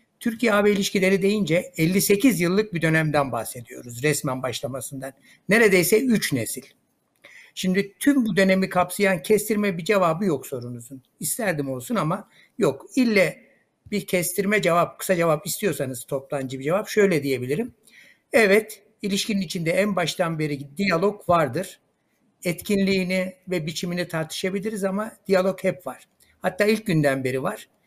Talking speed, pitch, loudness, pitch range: 130 wpm, 185 Hz, -23 LUFS, 150-205 Hz